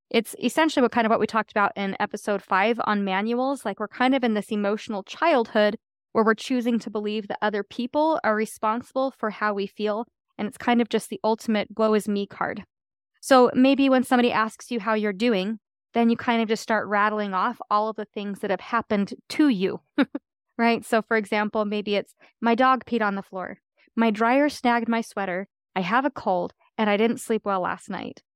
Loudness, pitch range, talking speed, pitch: -24 LUFS, 210-240 Hz, 215 wpm, 220 Hz